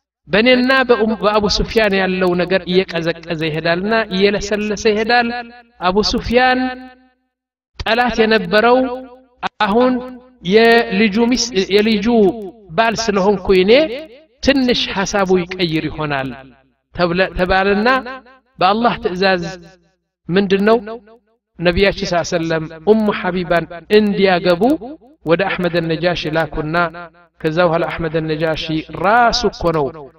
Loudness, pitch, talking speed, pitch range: -15 LUFS, 200 Hz, 80 wpm, 175-235 Hz